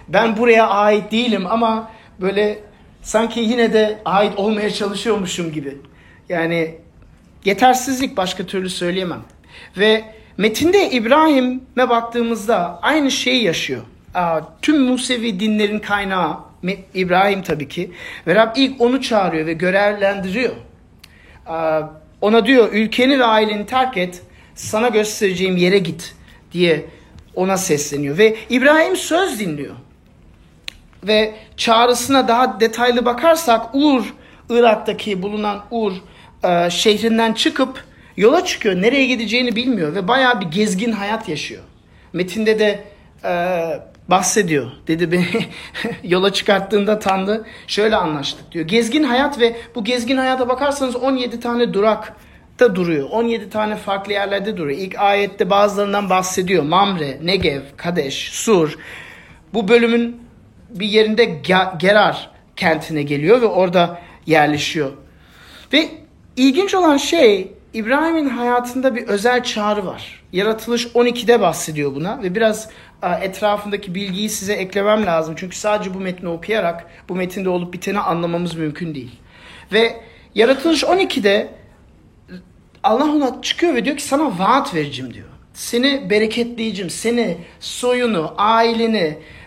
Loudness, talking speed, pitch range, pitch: -17 LUFS, 120 wpm, 180-235 Hz, 210 Hz